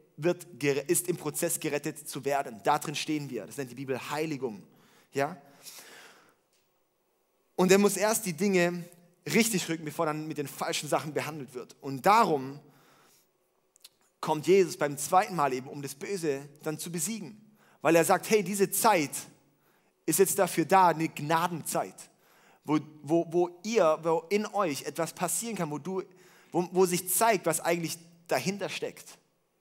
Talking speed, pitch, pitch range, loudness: 160 wpm, 170 Hz, 150-190 Hz, -29 LUFS